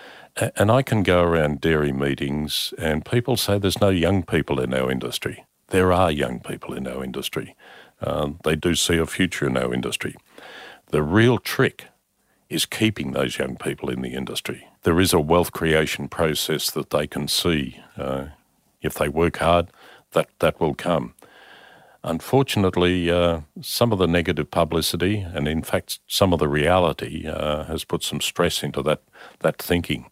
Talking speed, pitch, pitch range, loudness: 170 wpm, 85 Hz, 75-95 Hz, -22 LUFS